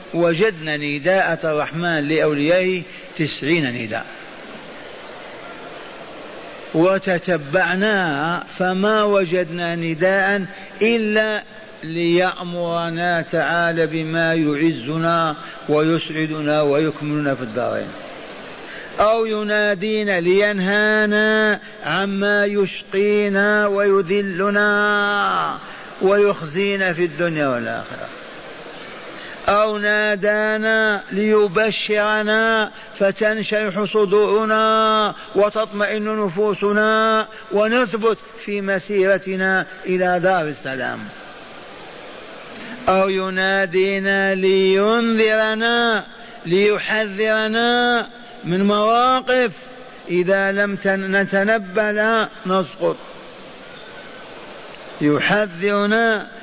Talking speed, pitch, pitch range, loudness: 55 wpm, 200 Hz, 175-215 Hz, -18 LUFS